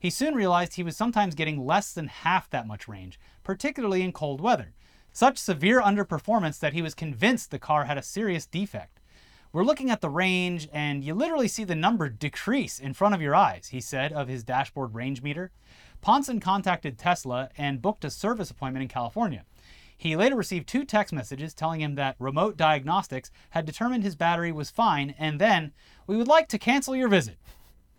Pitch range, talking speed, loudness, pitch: 140-210 Hz, 195 wpm, -26 LUFS, 170 Hz